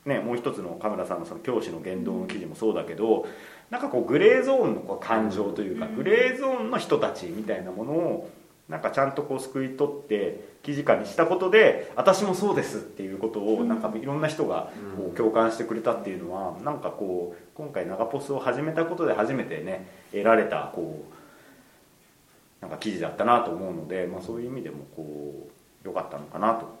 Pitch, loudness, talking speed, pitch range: 135 Hz, -26 LUFS, 415 characters per minute, 110-175 Hz